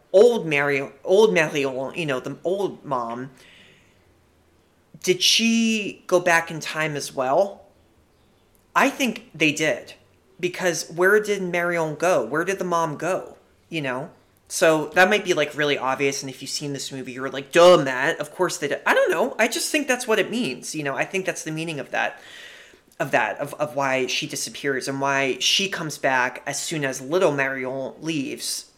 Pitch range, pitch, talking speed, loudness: 135-180 Hz, 155 Hz, 190 wpm, -22 LUFS